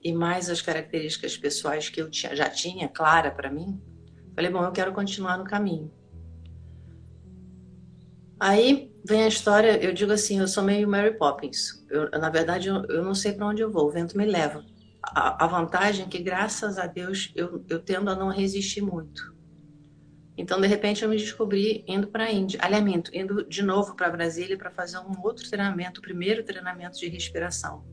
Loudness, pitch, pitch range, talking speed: -26 LUFS, 180 Hz, 155-200 Hz, 190 wpm